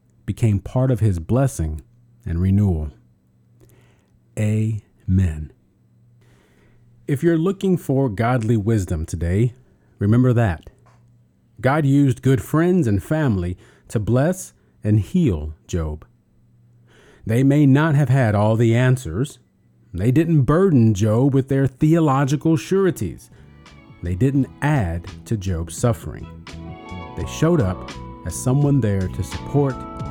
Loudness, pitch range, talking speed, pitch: -20 LUFS, 90-135 Hz, 115 wpm, 115 Hz